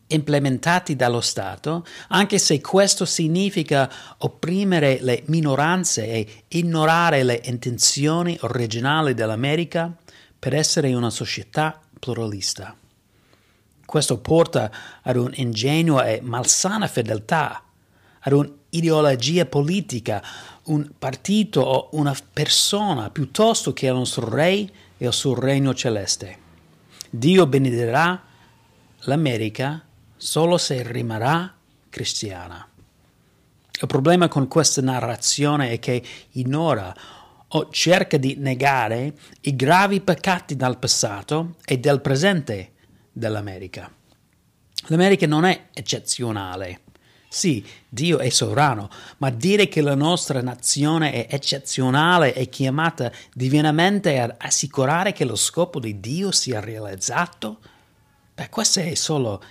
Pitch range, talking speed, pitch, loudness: 120-160 Hz, 110 wpm, 135 Hz, -20 LUFS